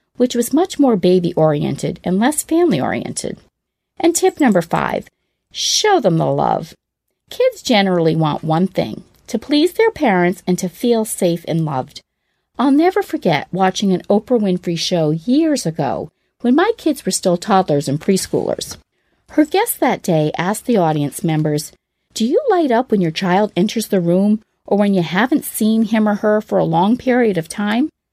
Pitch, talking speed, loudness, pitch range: 205 Hz, 175 wpm, -16 LUFS, 175-265 Hz